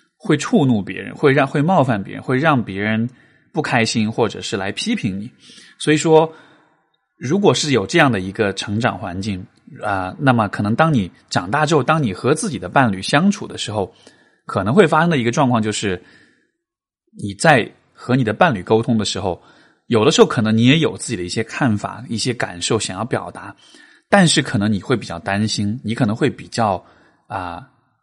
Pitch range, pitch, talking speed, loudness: 105-155 Hz, 120 Hz, 285 characters per minute, -18 LUFS